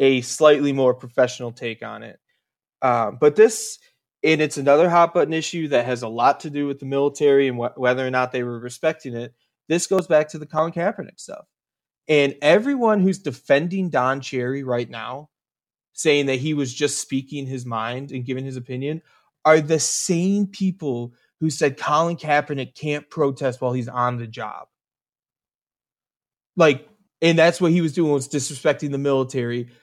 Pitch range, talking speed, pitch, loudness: 125-160 Hz, 175 wpm, 140 Hz, -21 LUFS